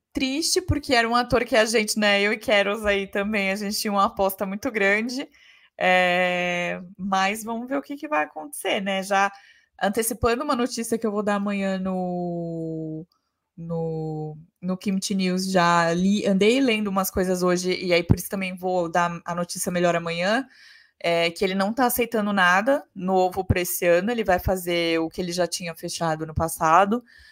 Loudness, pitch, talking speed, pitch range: -23 LUFS, 195 Hz, 185 wpm, 175-215 Hz